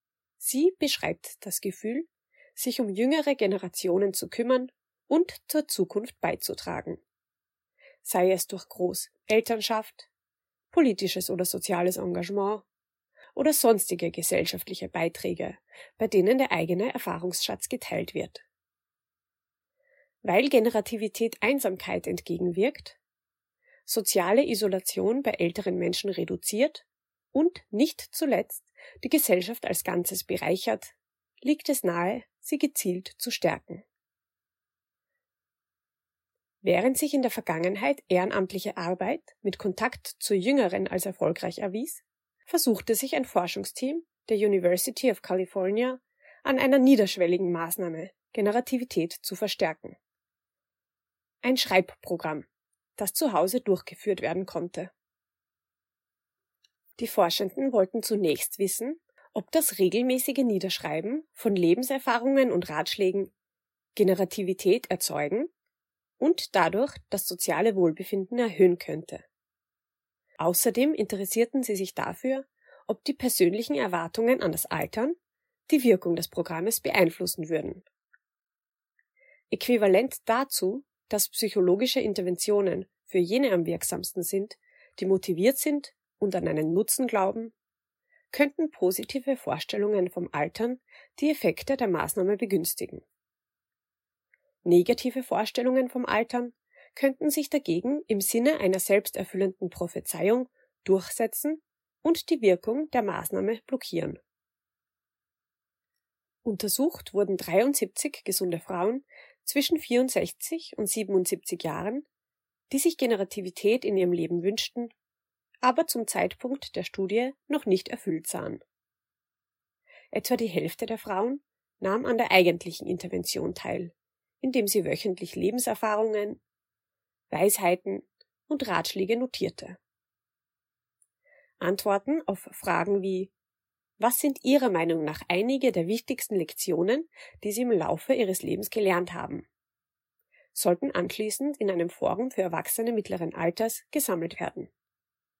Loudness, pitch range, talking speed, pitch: -27 LUFS, 185-260 Hz, 105 wpm, 215 Hz